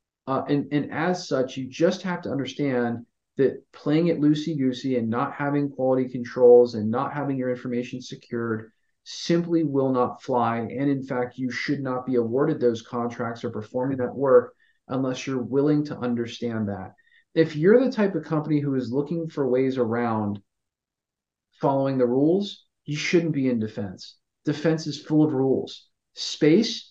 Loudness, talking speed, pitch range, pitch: -24 LUFS, 170 wpm, 120-155 Hz, 130 Hz